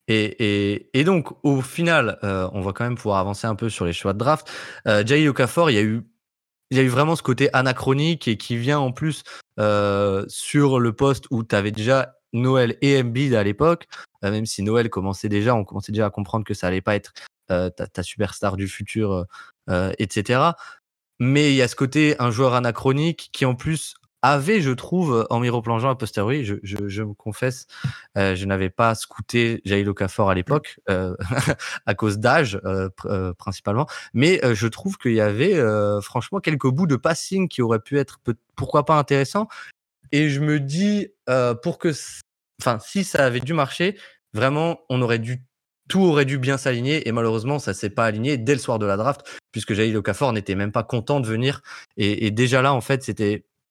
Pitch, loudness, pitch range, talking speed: 120 Hz, -22 LUFS, 105-140 Hz, 210 wpm